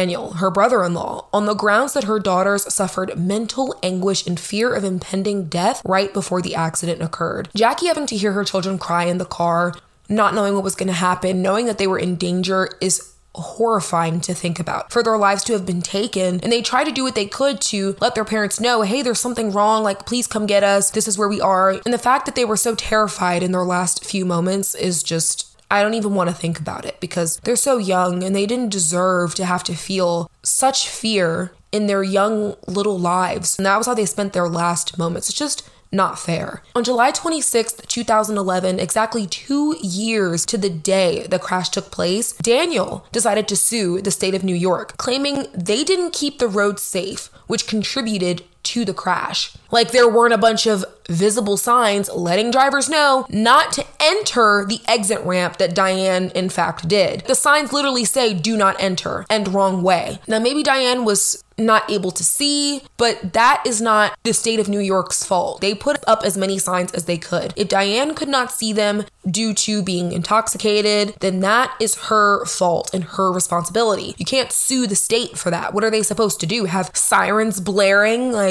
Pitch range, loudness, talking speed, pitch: 185-230 Hz, -18 LUFS, 205 wpm, 200 Hz